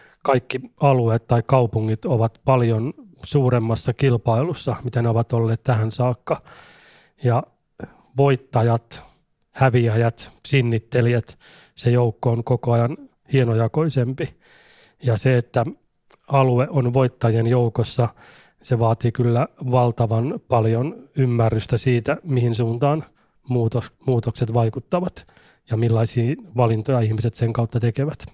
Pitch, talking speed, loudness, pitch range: 120 Hz, 105 wpm, -21 LUFS, 115-130 Hz